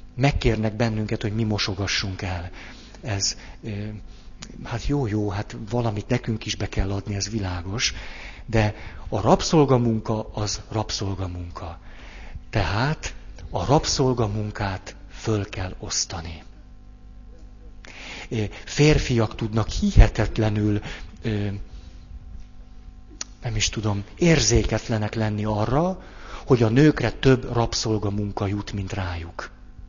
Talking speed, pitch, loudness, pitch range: 95 wpm, 105 Hz, -24 LUFS, 95-115 Hz